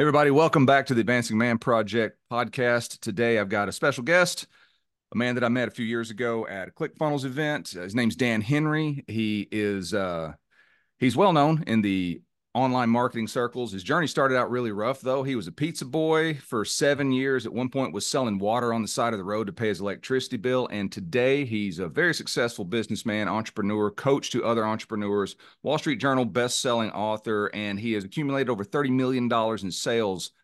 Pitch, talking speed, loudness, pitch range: 120 Hz, 205 wpm, -26 LUFS, 105-135 Hz